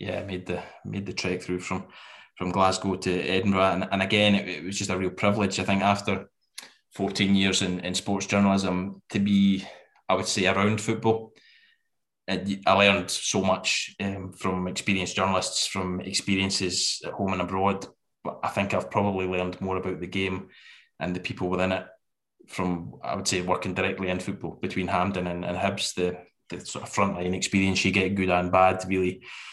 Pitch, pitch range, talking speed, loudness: 95 Hz, 90-100 Hz, 190 wpm, -26 LUFS